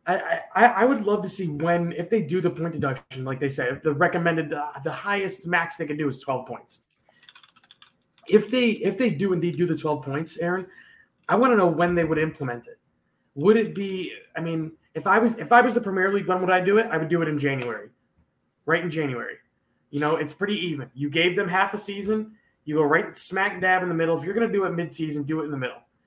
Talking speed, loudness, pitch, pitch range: 250 wpm, -24 LUFS, 170 Hz, 155-200 Hz